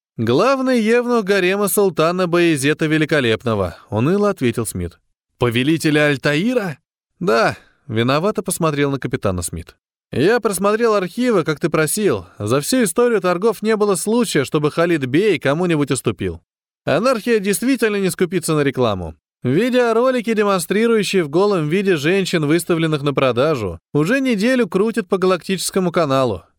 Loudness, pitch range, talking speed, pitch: -17 LUFS, 140-210 Hz, 125 wpm, 175 Hz